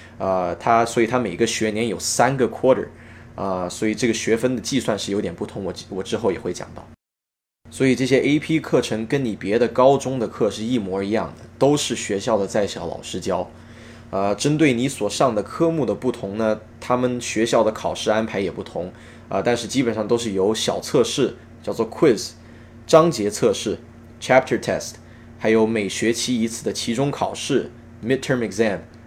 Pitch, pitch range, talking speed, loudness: 115 Hz, 110-125 Hz, 320 characters per minute, -21 LUFS